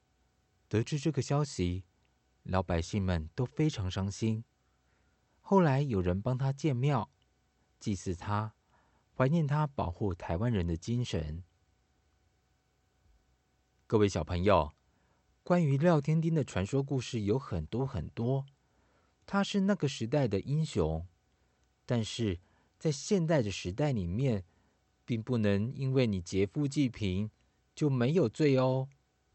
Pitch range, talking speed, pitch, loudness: 90-135 Hz, 185 characters per minute, 110 Hz, -32 LUFS